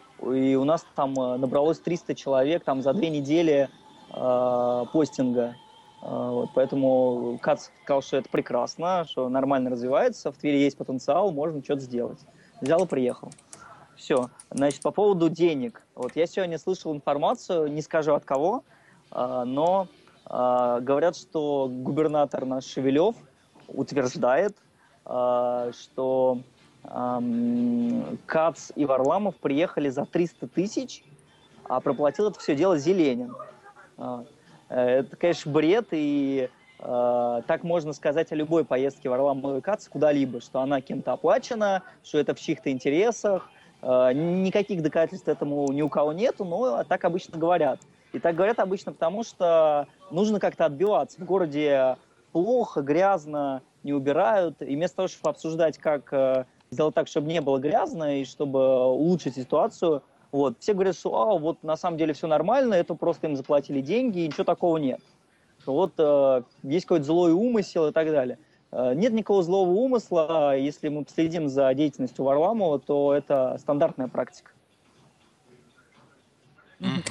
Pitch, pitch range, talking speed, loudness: 150 Hz, 135-175 Hz, 140 wpm, -25 LUFS